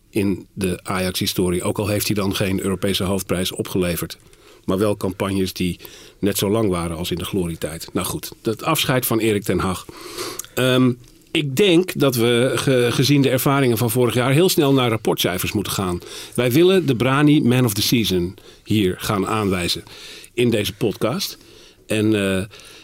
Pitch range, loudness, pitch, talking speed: 95-130 Hz, -20 LUFS, 110 Hz, 175 wpm